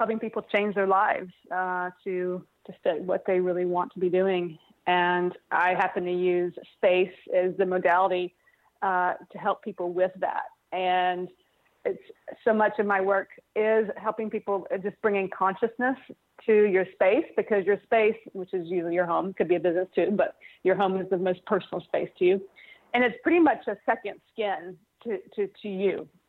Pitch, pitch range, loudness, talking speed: 190 Hz, 180-215 Hz, -27 LUFS, 185 wpm